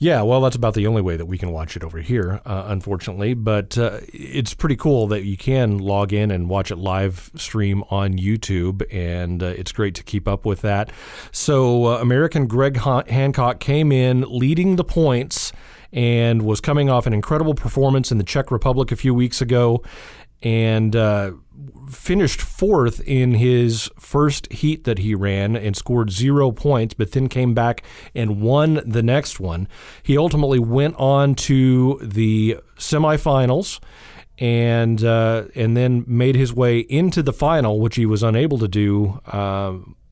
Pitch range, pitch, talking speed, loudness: 105-135 Hz, 120 Hz, 170 wpm, -19 LUFS